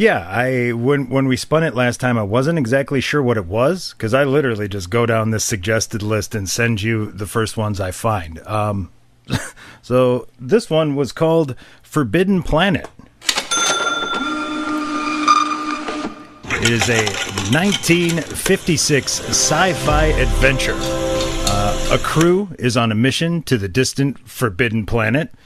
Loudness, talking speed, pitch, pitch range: -18 LUFS, 140 wpm, 125 Hz, 110-160 Hz